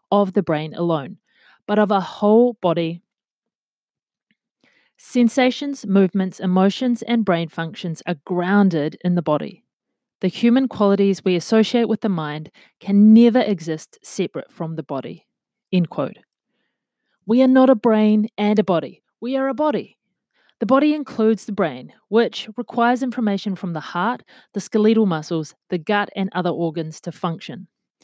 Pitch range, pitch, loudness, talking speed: 175-230 Hz, 200 Hz, -19 LUFS, 150 wpm